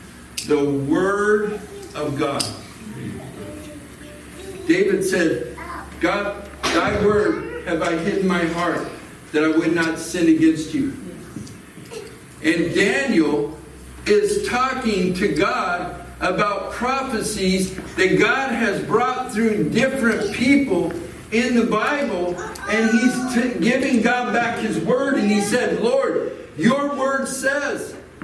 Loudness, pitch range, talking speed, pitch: -20 LUFS, 170-255 Hz, 115 wpm, 210 Hz